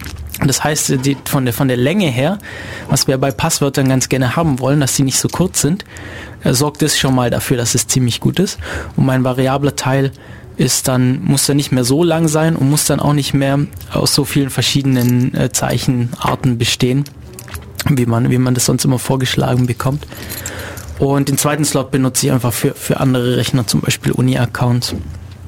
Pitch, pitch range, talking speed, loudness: 130 Hz, 120-140 Hz, 185 wpm, -15 LUFS